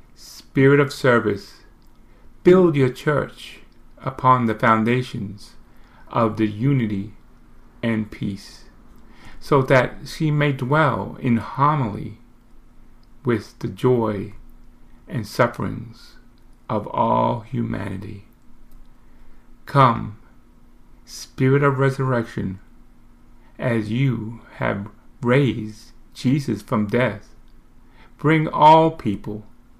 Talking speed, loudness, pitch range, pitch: 85 wpm, -20 LUFS, 110-130 Hz, 120 Hz